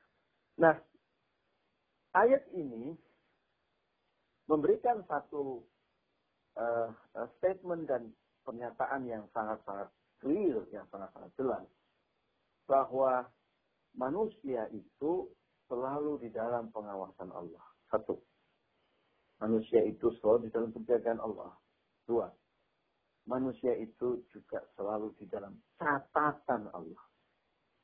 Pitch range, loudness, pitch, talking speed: 110-135 Hz, -35 LUFS, 120 Hz, 85 wpm